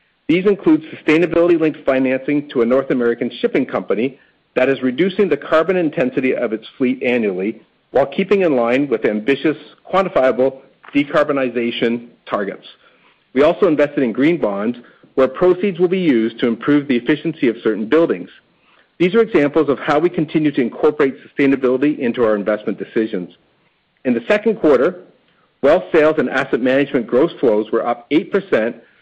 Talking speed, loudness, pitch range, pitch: 155 wpm, -17 LUFS, 125-170 Hz, 140 Hz